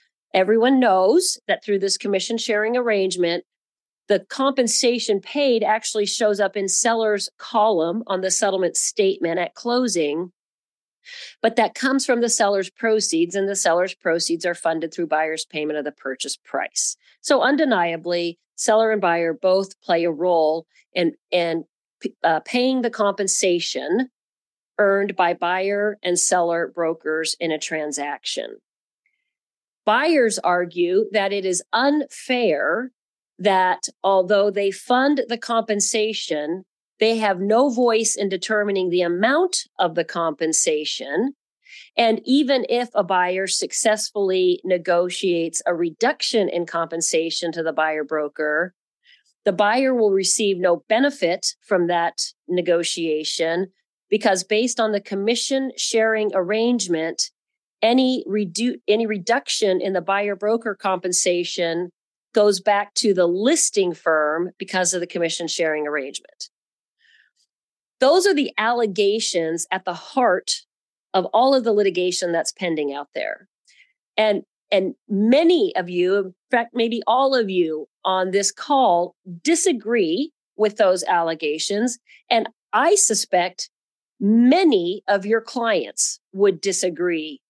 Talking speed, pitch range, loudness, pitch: 125 wpm, 175-230 Hz, -20 LUFS, 200 Hz